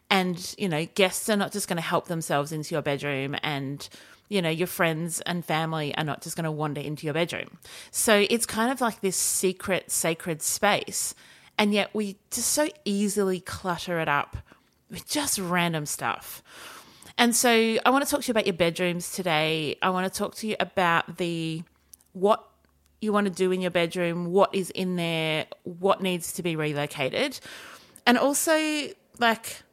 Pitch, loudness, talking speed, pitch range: 180 Hz, -26 LUFS, 185 wpm, 165-210 Hz